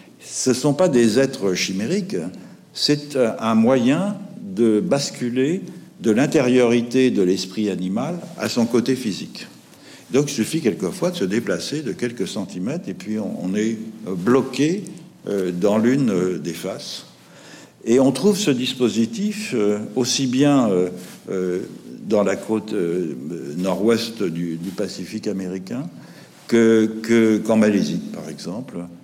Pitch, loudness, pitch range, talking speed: 115 Hz, -21 LUFS, 105-130 Hz, 125 wpm